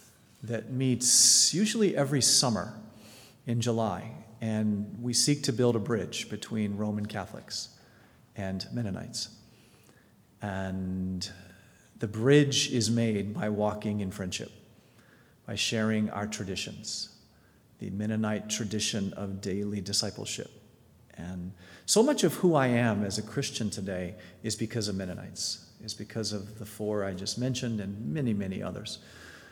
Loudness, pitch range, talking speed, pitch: -29 LUFS, 100-120 Hz, 130 wpm, 110 Hz